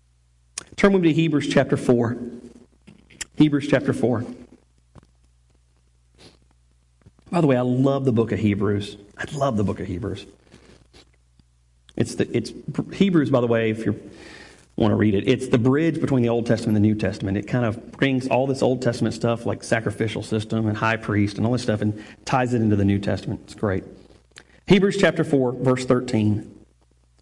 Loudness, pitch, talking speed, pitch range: -22 LUFS, 110 Hz, 180 wpm, 100-125 Hz